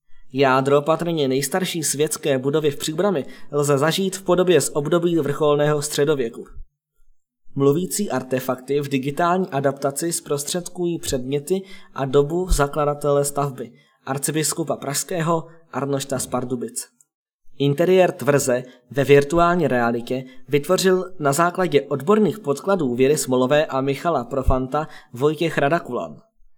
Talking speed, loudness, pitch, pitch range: 105 wpm, -21 LUFS, 145 Hz, 135-170 Hz